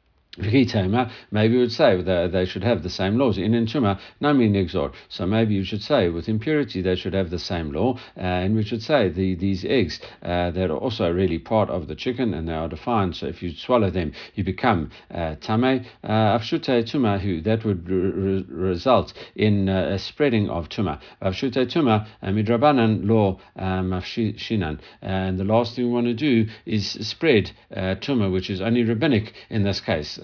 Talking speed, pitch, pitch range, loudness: 195 wpm, 100 Hz, 95-115 Hz, -23 LUFS